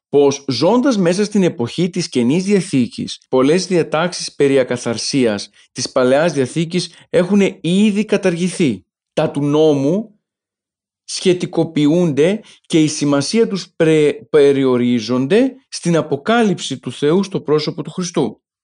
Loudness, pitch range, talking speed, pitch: -16 LUFS, 140-185 Hz, 115 wpm, 165 Hz